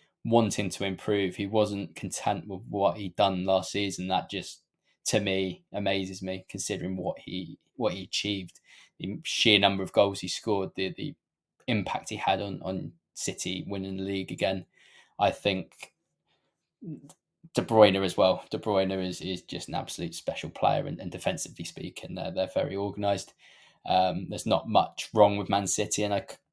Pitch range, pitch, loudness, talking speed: 95-100 Hz, 95 Hz, -29 LUFS, 170 wpm